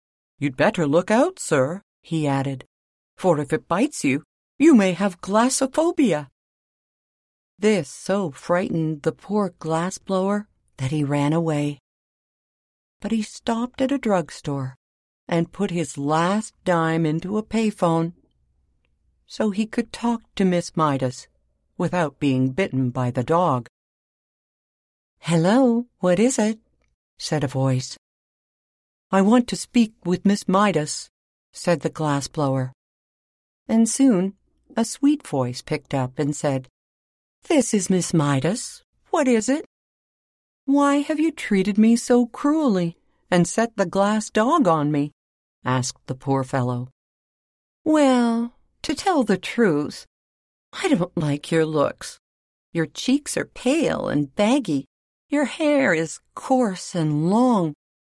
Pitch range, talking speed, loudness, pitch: 140-225 Hz, 130 wpm, -22 LUFS, 175 Hz